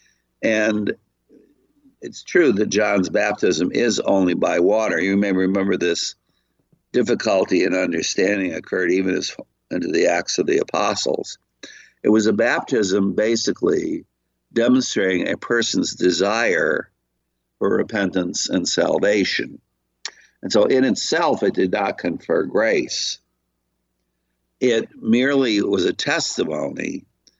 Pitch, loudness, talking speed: 95 Hz, -20 LUFS, 115 wpm